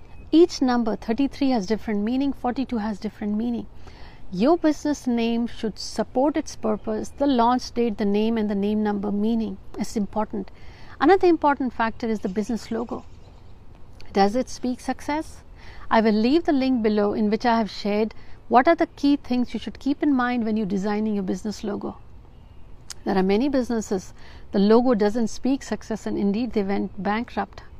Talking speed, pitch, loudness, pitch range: 175 wpm, 225 Hz, -23 LUFS, 210-255 Hz